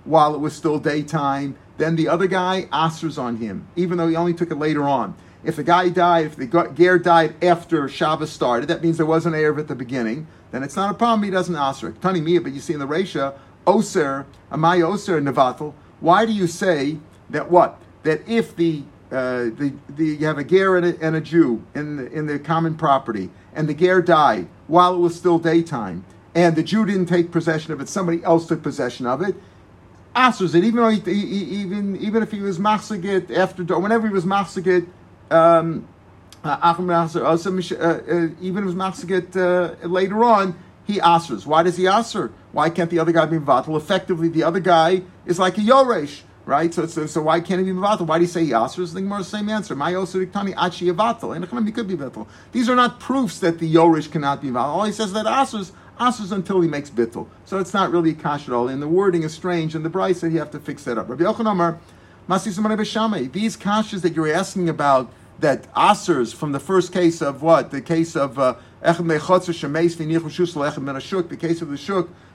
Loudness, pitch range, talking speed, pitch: -20 LUFS, 150-185 Hz, 205 wpm, 170 Hz